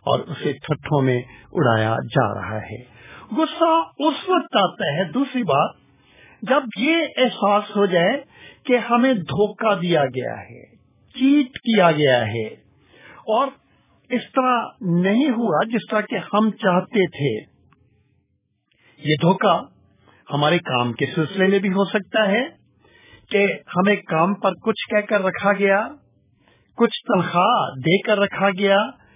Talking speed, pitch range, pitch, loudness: 140 wpm, 155-230 Hz, 200 Hz, -20 LUFS